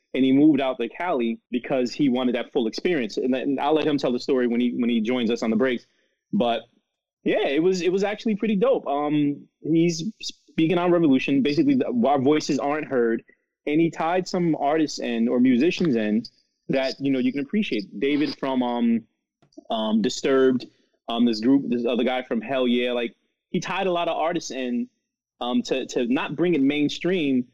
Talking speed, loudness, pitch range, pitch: 200 wpm, -23 LUFS, 125-185 Hz, 145 Hz